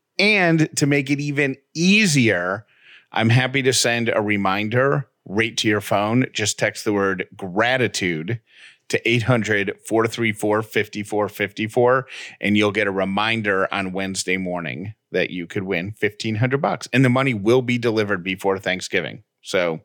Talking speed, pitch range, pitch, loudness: 140 wpm, 100-130 Hz, 110 Hz, -20 LUFS